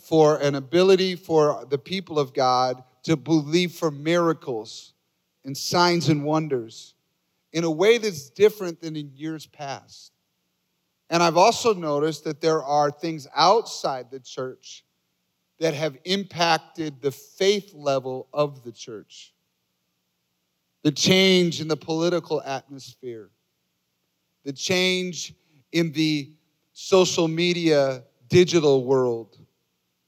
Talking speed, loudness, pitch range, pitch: 120 wpm, -22 LUFS, 135-170 Hz, 155 Hz